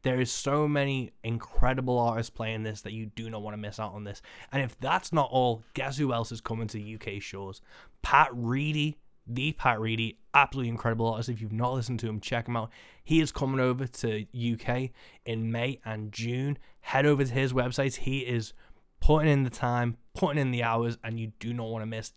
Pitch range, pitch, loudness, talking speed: 110-135 Hz, 120 Hz, -29 LUFS, 215 wpm